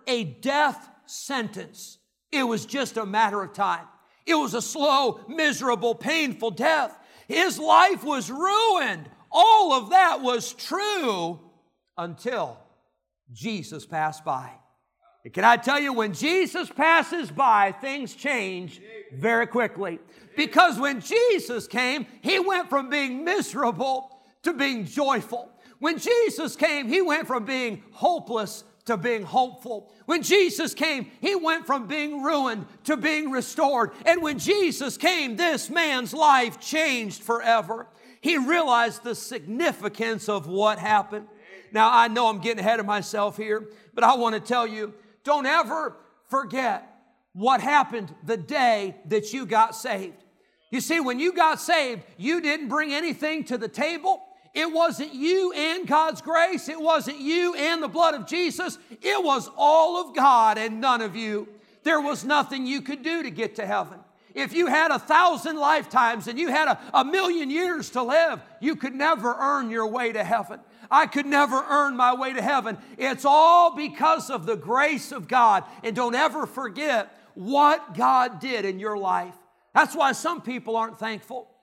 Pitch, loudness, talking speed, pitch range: 265 Hz, -23 LUFS, 160 wpm, 225-310 Hz